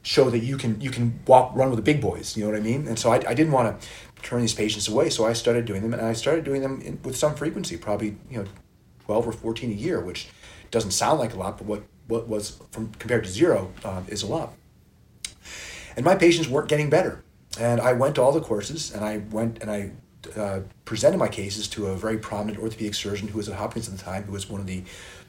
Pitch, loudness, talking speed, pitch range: 110 Hz, -25 LUFS, 255 wpm, 105-120 Hz